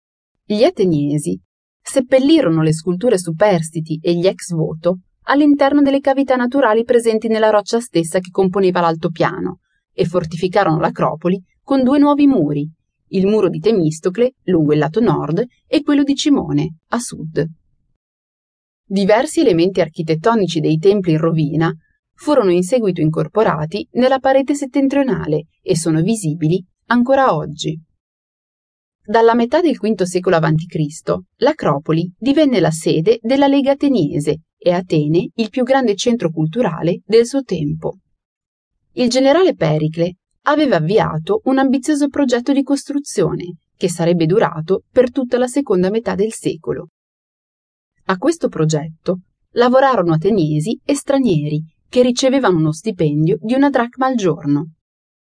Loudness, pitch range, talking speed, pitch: -16 LUFS, 165-255 Hz, 130 wpm, 195 Hz